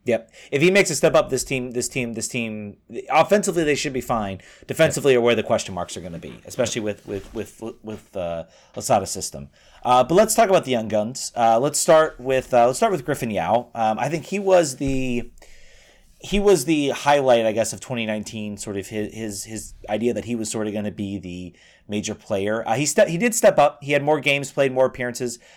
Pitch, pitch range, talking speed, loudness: 120 Hz, 110-145 Hz, 235 wpm, -21 LUFS